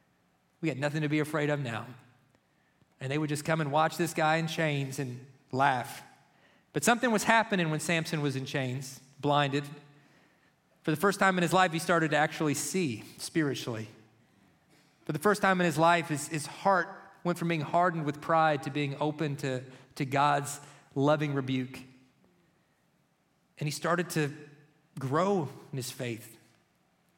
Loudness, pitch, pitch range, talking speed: -30 LUFS, 150 Hz, 140-165 Hz, 170 wpm